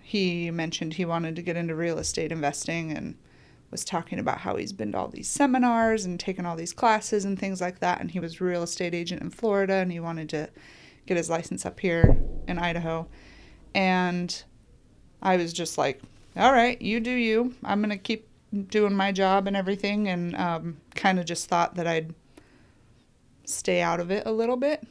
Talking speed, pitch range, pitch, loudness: 200 wpm, 170-205 Hz, 180 Hz, -27 LUFS